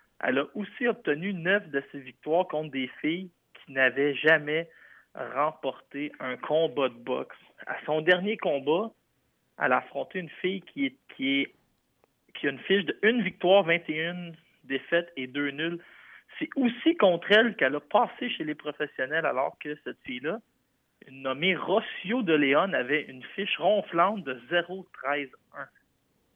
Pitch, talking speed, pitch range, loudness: 170 Hz, 155 wpm, 145-200 Hz, -28 LUFS